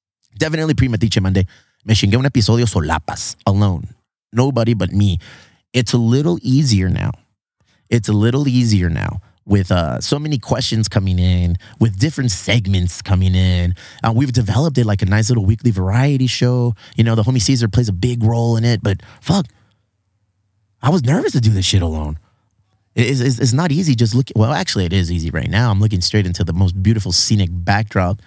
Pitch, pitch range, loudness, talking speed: 110 Hz, 100-125 Hz, -16 LUFS, 190 wpm